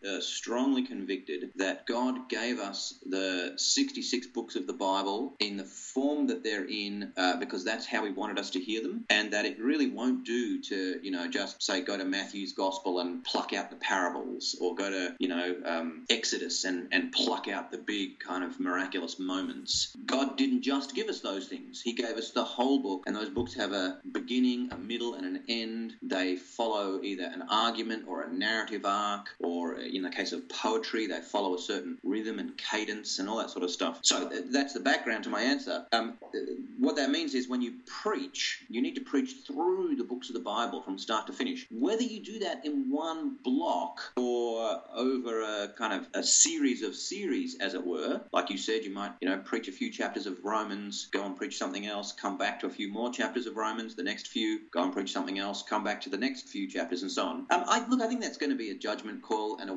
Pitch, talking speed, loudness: 140 Hz, 225 wpm, -32 LUFS